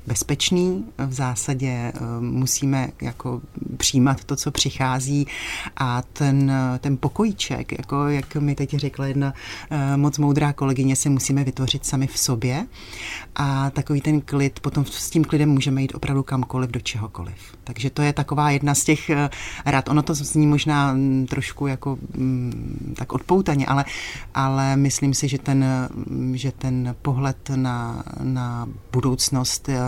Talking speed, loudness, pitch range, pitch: 140 wpm, -22 LUFS, 130-145 Hz, 135 Hz